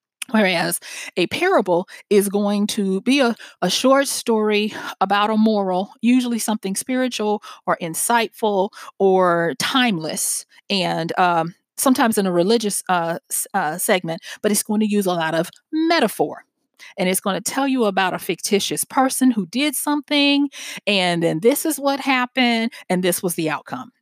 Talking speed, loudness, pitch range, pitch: 155 wpm, -19 LUFS, 185-255 Hz, 205 Hz